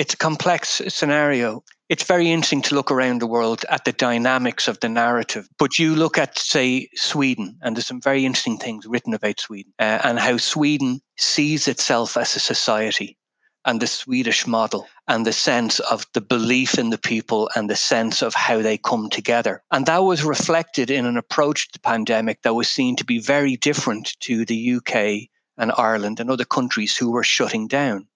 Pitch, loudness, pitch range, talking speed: 130 Hz, -20 LUFS, 115-150 Hz, 195 wpm